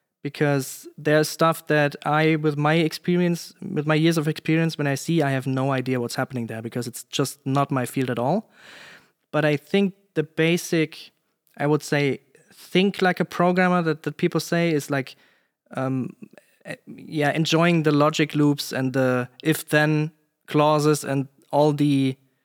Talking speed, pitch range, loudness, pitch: 165 wpm, 140-165 Hz, -23 LUFS, 150 Hz